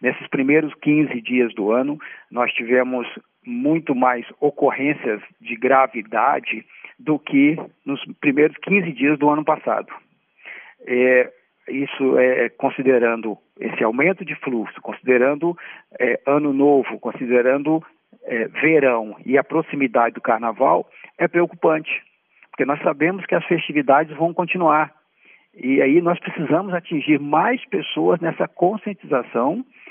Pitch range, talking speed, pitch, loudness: 130-170 Hz, 120 wpm, 145 Hz, -20 LUFS